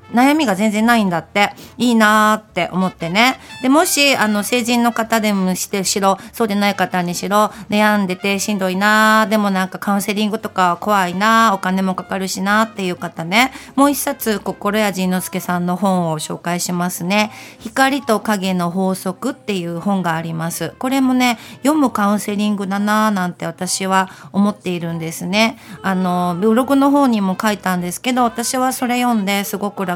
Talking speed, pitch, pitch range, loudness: 365 characters per minute, 205 Hz, 185-225 Hz, -17 LUFS